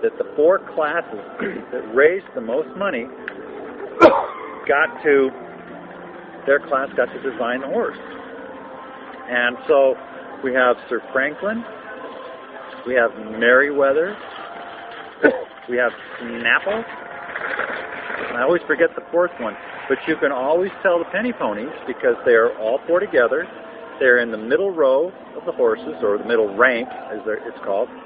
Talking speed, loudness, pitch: 140 wpm, -20 LUFS, 220 Hz